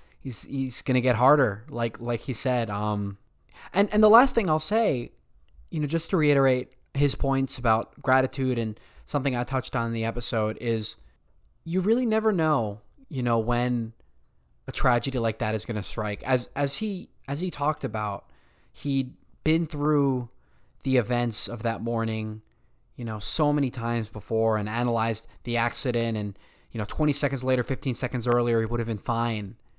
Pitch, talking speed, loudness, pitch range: 120 Hz, 175 wpm, -26 LUFS, 110-140 Hz